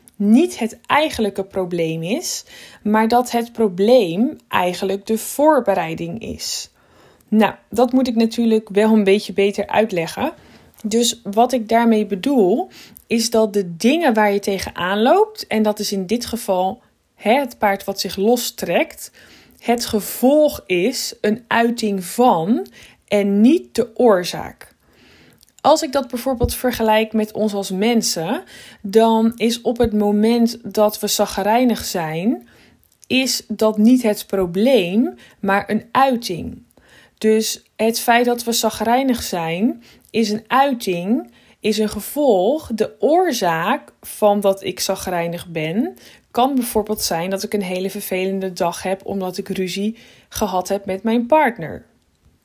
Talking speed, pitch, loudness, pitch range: 140 wpm, 220 Hz, -18 LUFS, 195-240 Hz